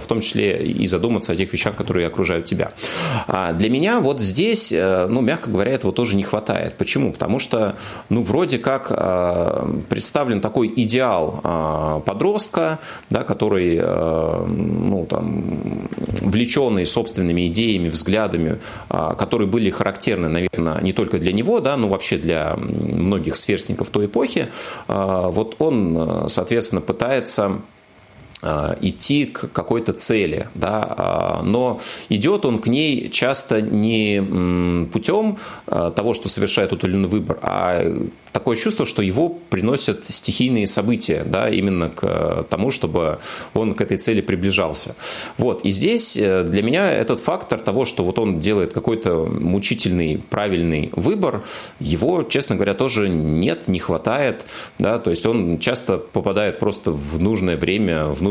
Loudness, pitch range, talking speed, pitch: -19 LUFS, 85-115 Hz, 135 wpm, 100 Hz